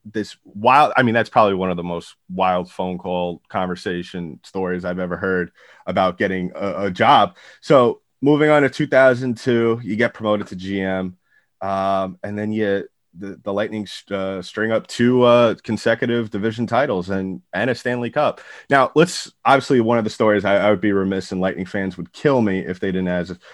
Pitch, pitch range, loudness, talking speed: 100 Hz, 95-120 Hz, -19 LUFS, 190 wpm